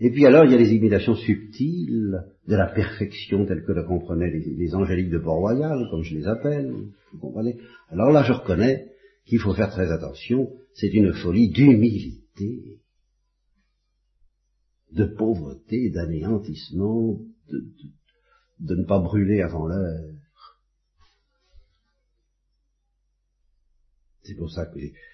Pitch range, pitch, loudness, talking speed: 85-115 Hz, 100 Hz, -22 LUFS, 135 wpm